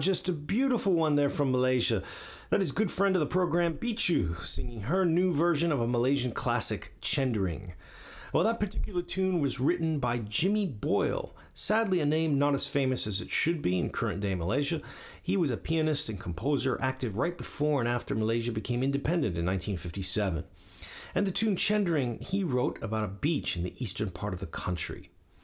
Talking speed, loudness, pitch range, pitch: 185 wpm, -29 LUFS, 100-170 Hz, 130 Hz